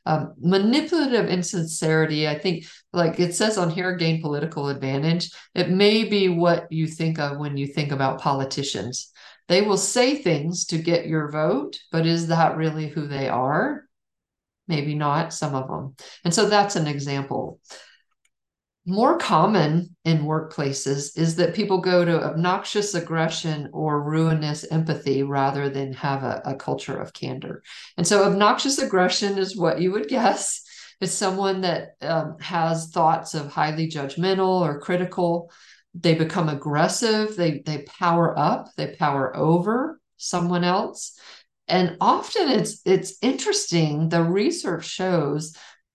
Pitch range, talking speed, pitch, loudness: 155-185 Hz, 145 wpm, 165 Hz, -23 LUFS